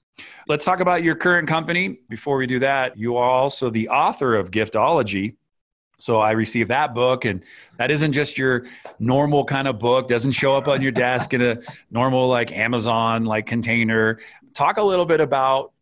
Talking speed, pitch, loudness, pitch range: 185 wpm, 130 Hz, -20 LUFS, 120-140 Hz